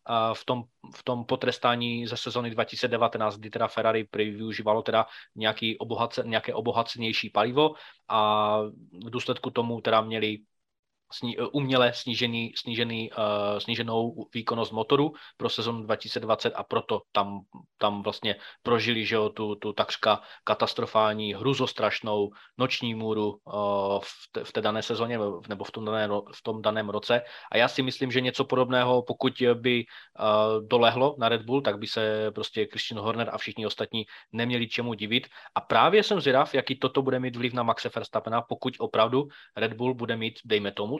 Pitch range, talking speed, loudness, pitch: 110-125 Hz, 155 wpm, -27 LUFS, 115 Hz